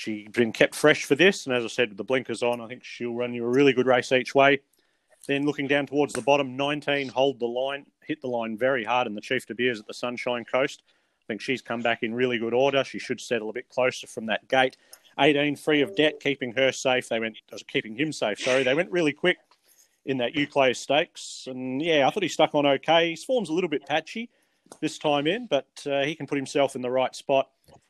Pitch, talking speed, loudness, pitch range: 135 Hz, 250 wpm, -25 LUFS, 125-145 Hz